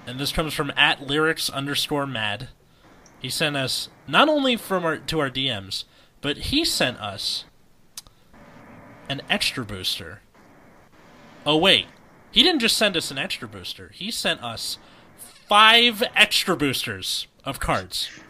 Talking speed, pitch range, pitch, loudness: 140 wpm, 130-200 Hz, 145 Hz, -21 LUFS